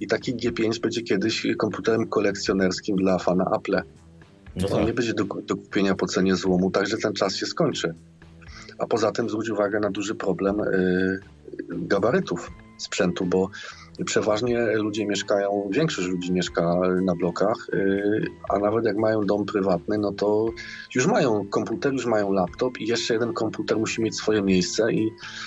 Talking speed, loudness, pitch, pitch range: 165 wpm, -24 LUFS, 100 Hz, 90-110 Hz